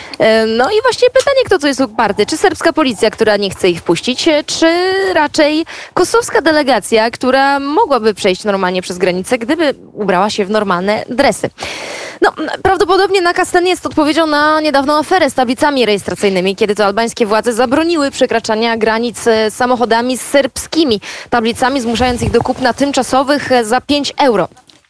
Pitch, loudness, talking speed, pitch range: 255 Hz, -13 LUFS, 150 wpm, 220-310 Hz